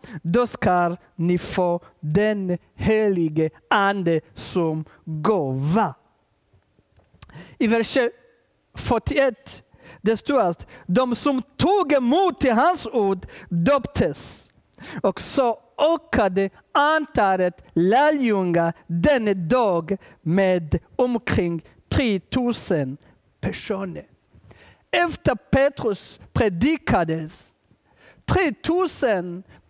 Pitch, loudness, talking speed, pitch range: 195 Hz, -22 LUFS, 75 wpm, 170-250 Hz